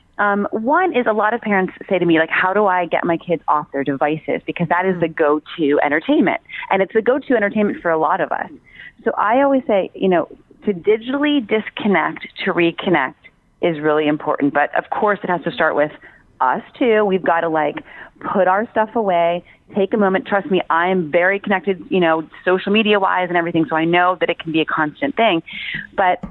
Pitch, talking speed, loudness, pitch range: 185 Hz, 220 wpm, -18 LUFS, 165-210 Hz